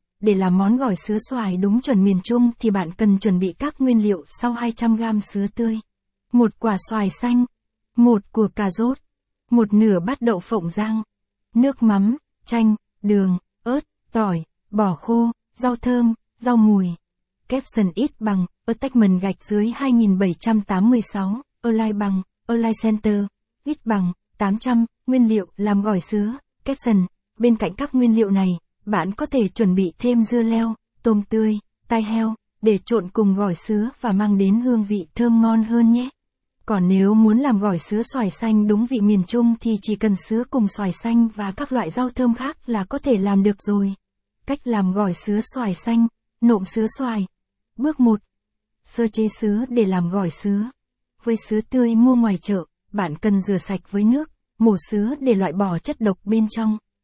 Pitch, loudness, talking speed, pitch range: 220 Hz, -20 LUFS, 185 wpm, 200-235 Hz